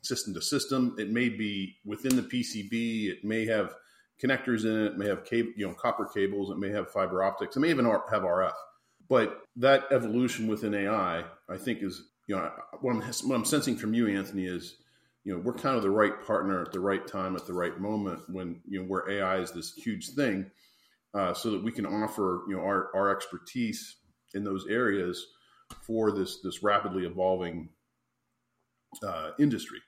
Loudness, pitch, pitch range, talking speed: -30 LUFS, 105 Hz, 95-115 Hz, 195 wpm